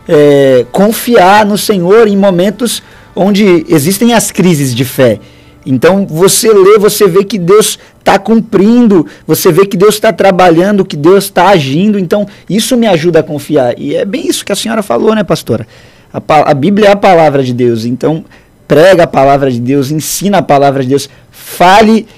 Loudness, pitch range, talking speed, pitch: -7 LUFS, 145-210 Hz, 180 wpm, 190 Hz